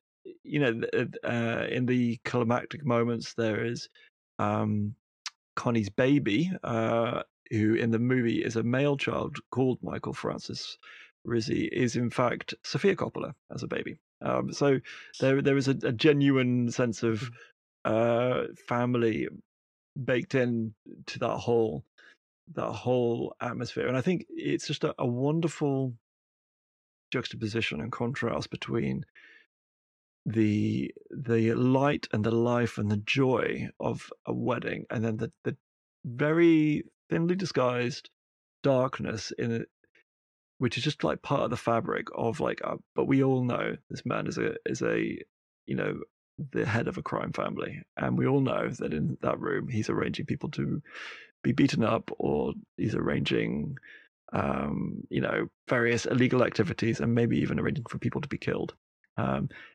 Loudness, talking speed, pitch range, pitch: -29 LUFS, 150 wpm, 115-135 Hz, 120 Hz